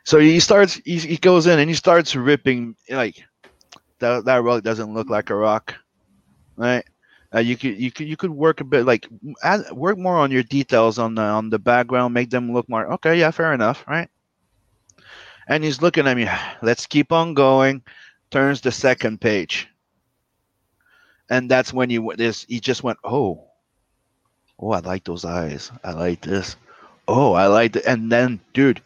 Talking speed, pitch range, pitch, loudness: 185 wpm, 115-145 Hz, 125 Hz, -19 LUFS